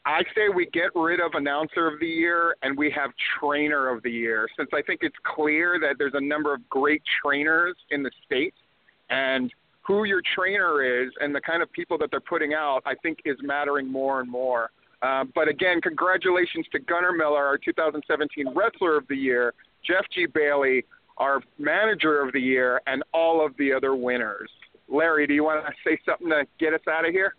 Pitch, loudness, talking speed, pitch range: 150 Hz, -24 LUFS, 205 wpm, 135-165 Hz